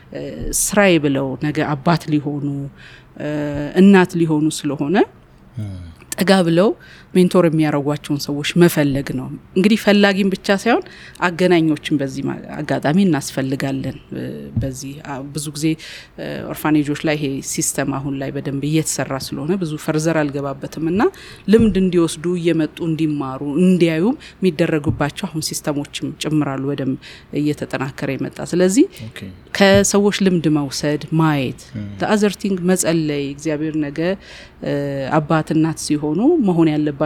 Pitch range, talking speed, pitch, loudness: 140-175 Hz, 105 wpm, 155 Hz, -18 LUFS